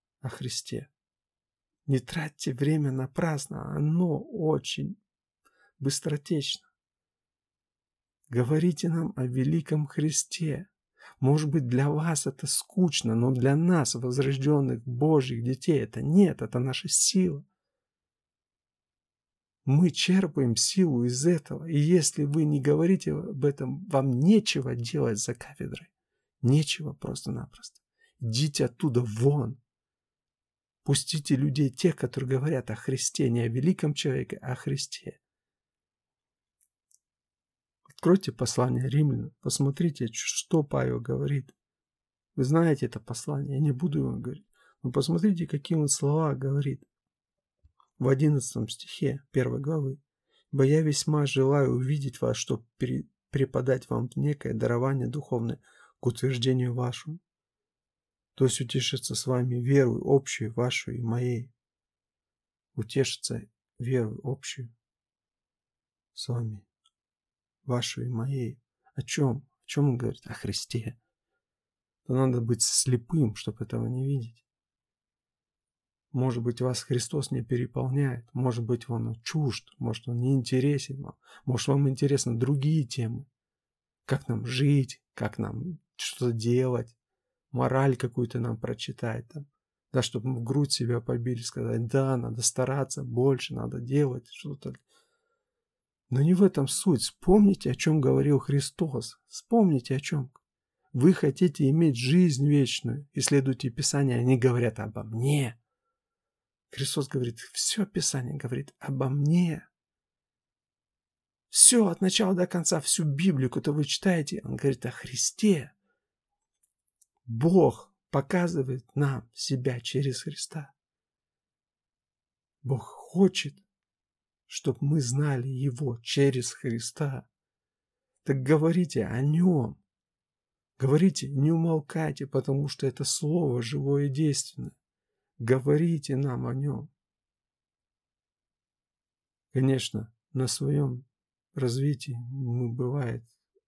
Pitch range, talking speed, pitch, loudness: 125-155 Hz, 115 wpm, 135 Hz, -27 LUFS